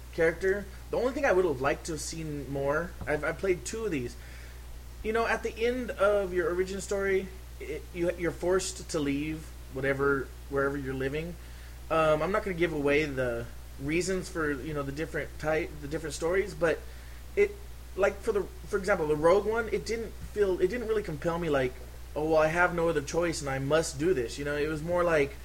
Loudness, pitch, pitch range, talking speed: -30 LUFS, 165 Hz, 145-195 Hz, 220 wpm